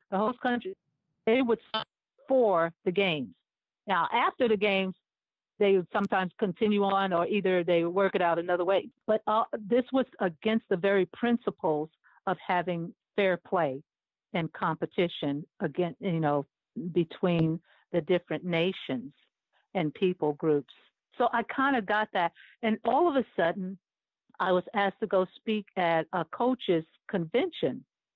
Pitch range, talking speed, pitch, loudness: 170-220 Hz, 155 wpm, 190 Hz, -29 LUFS